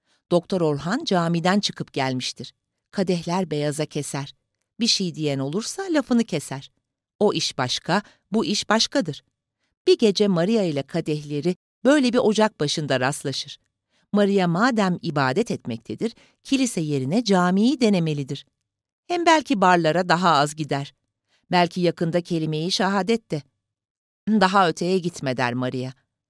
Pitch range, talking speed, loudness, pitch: 140-205 Hz, 125 wpm, -22 LUFS, 170 Hz